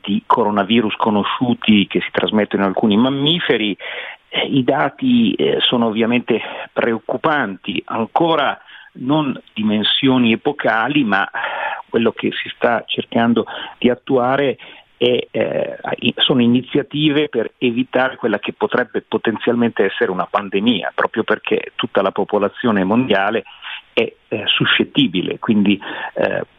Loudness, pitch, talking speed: -17 LUFS, 125 Hz, 115 wpm